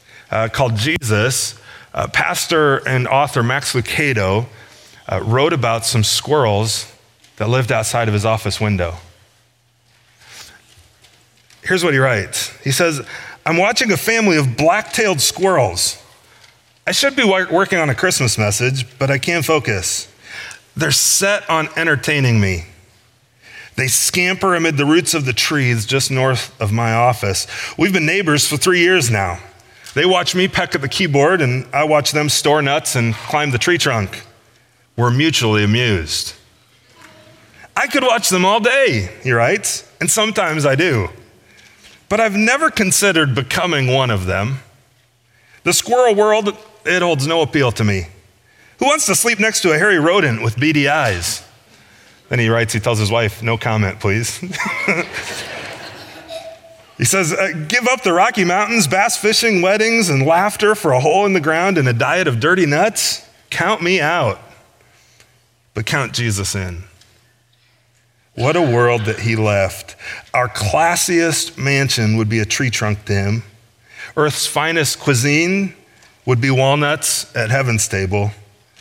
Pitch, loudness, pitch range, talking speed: 125 Hz, -15 LUFS, 115-165 Hz, 150 wpm